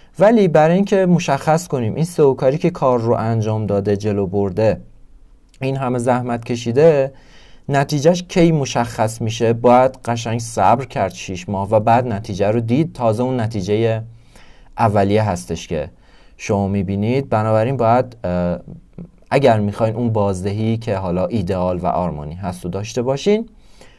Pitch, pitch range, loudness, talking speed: 115 Hz, 100-135 Hz, -18 LUFS, 140 wpm